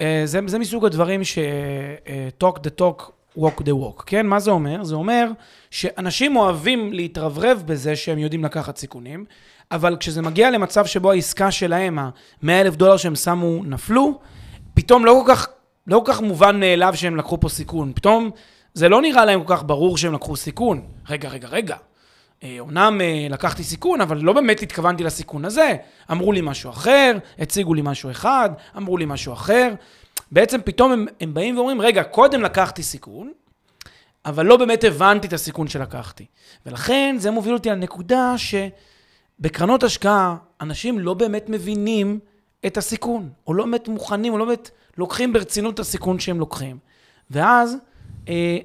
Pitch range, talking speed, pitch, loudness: 155-220 Hz, 160 wpm, 185 Hz, -19 LUFS